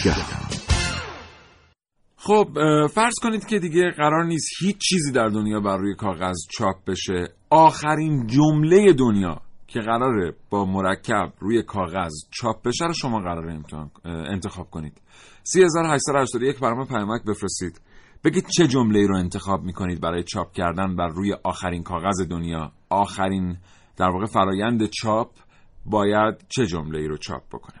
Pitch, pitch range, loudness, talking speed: 100 Hz, 90-140 Hz, -22 LUFS, 135 wpm